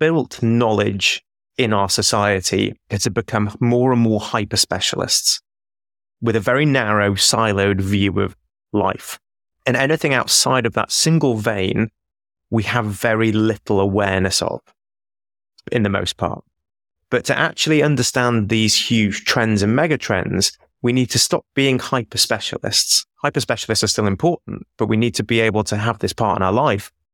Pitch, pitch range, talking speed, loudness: 110 Hz, 100-120 Hz, 160 wpm, -18 LUFS